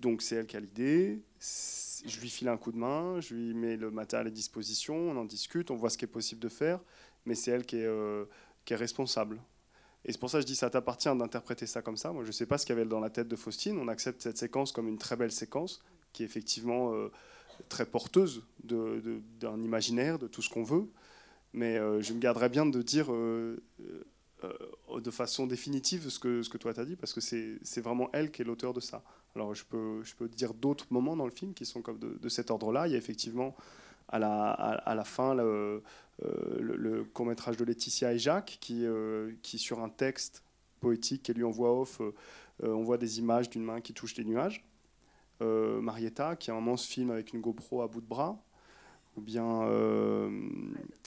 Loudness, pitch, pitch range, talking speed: -34 LUFS, 120 Hz, 115-125 Hz, 230 wpm